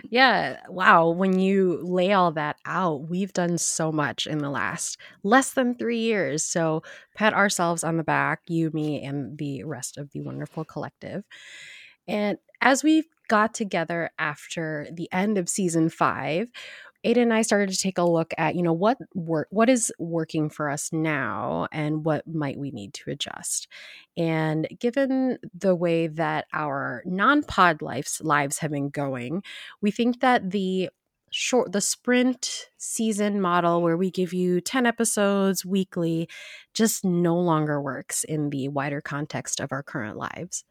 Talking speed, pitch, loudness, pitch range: 165 wpm, 175 Hz, -25 LUFS, 155-210 Hz